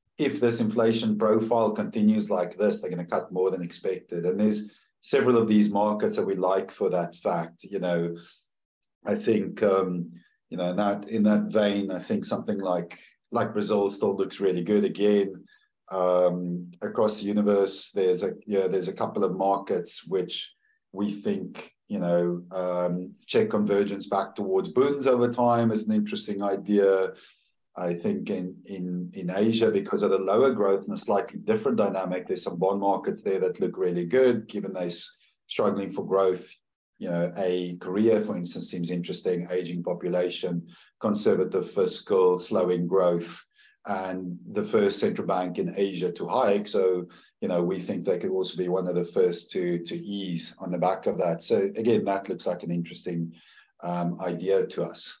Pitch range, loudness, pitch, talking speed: 90-105 Hz, -26 LUFS, 95 Hz, 180 wpm